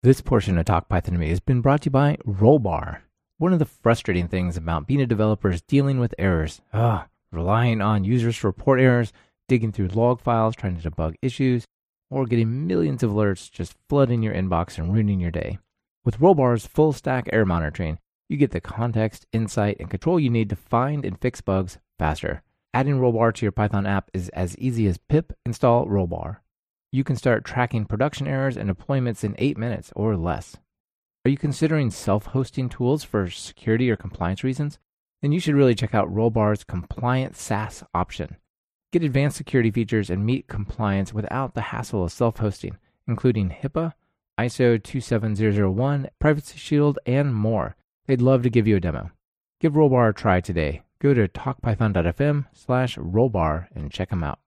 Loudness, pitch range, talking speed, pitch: -23 LUFS, 95-130 Hz, 180 wpm, 115 Hz